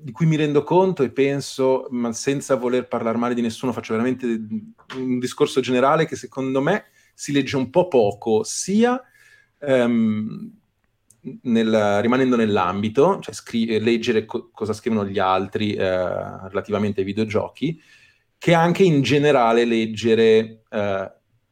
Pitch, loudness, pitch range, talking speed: 125 Hz, -21 LUFS, 110-140 Hz, 140 wpm